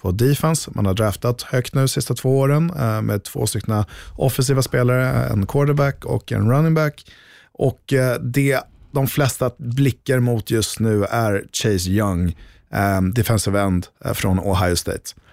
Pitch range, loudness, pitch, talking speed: 100-135 Hz, -20 LUFS, 120 Hz, 150 wpm